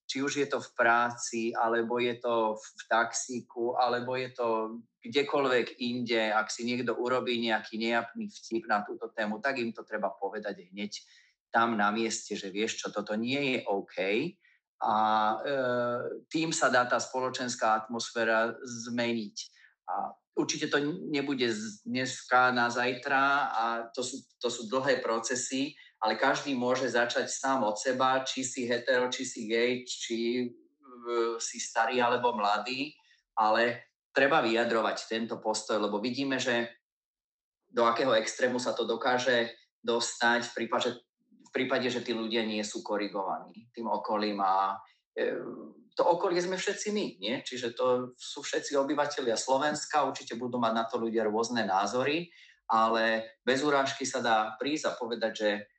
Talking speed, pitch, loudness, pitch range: 155 wpm, 120 Hz, -30 LUFS, 115-130 Hz